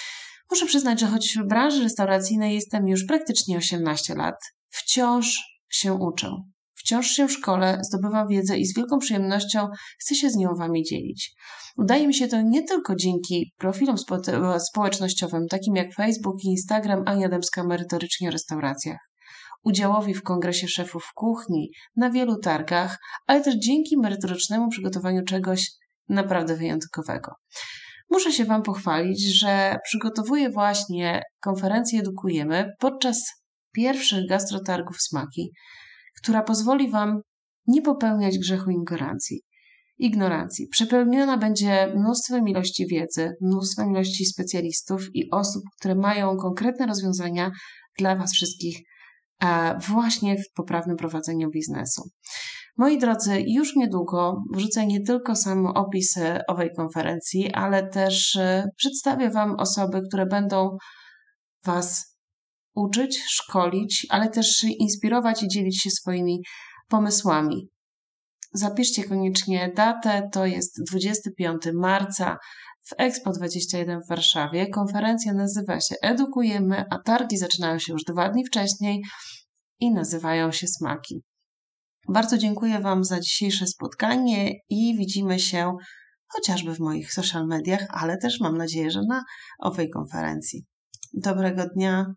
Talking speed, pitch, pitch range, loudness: 125 wpm, 195 Hz, 180-225 Hz, -24 LUFS